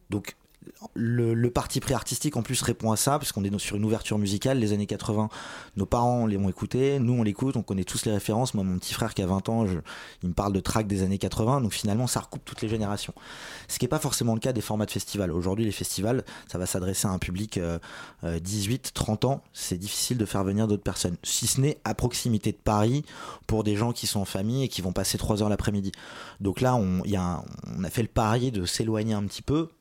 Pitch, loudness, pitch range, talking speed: 110 Hz, -27 LUFS, 100-120 Hz, 250 wpm